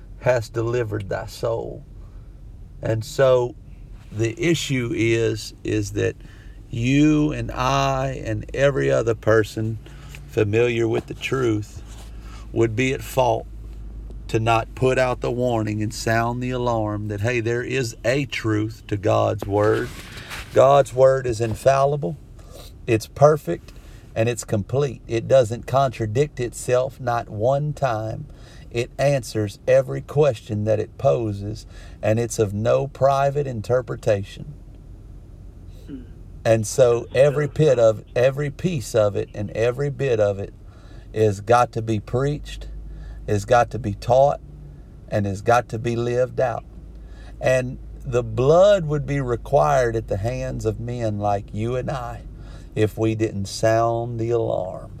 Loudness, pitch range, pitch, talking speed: -21 LUFS, 105-130 Hz, 115 Hz, 135 wpm